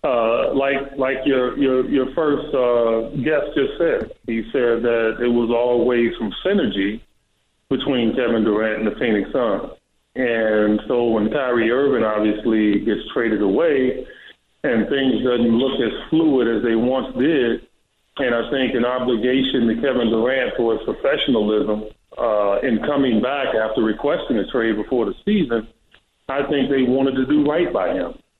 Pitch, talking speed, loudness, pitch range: 120 Hz, 160 wpm, -19 LUFS, 110-135 Hz